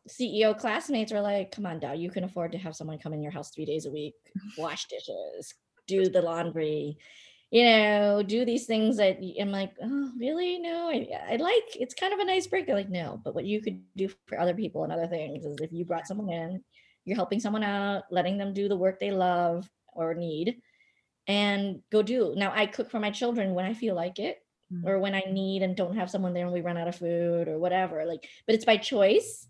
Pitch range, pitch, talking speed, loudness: 170-220 Hz, 195 Hz, 230 wpm, -29 LUFS